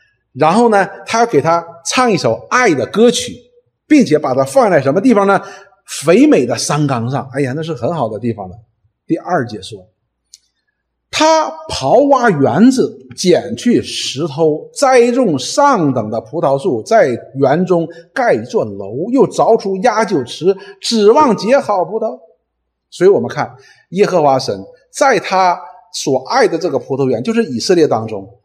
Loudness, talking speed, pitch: -13 LUFS, 225 characters per minute, 180 Hz